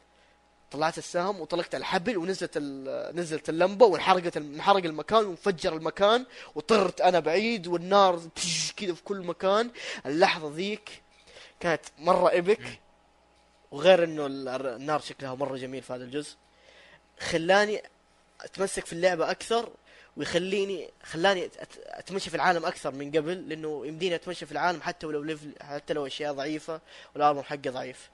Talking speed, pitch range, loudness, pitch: 130 wpm, 150-190 Hz, -28 LUFS, 170 Hz